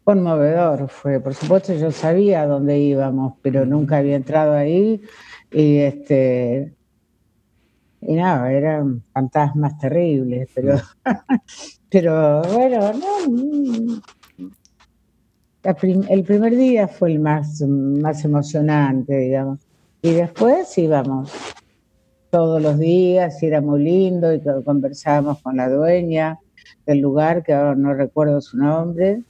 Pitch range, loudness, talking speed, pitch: 140-180 Hz, -18 LUFS, 120 wpm, 150 Hz